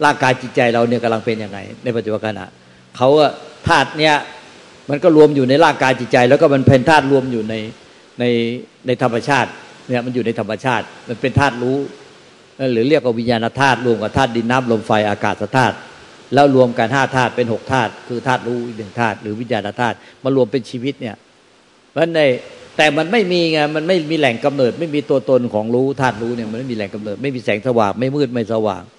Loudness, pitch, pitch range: -16 LUFS, 125 Hz, 115-135 Hz